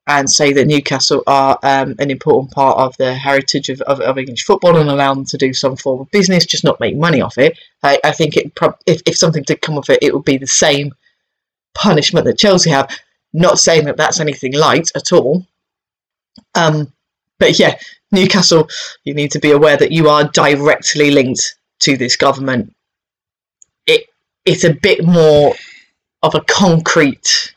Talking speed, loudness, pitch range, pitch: 185 wpm, -12 LUFS, 135-175 Hz, 145 Hz